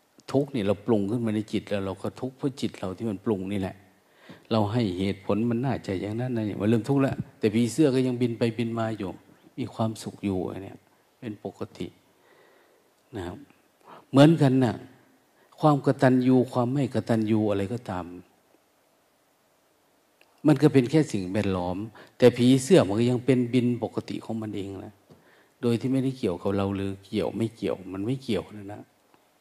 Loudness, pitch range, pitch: -26 LUFS, 100-130 Hz, 115 Hz